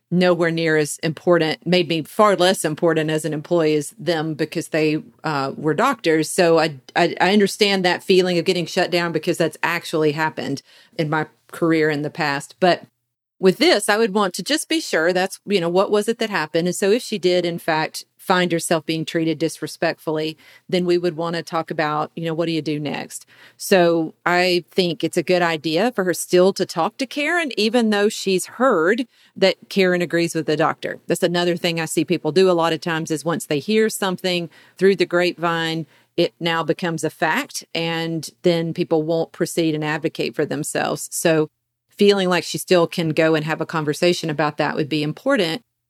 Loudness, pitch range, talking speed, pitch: -20 LUFS, 160-185 Hz, 205 wpm, 170 Hz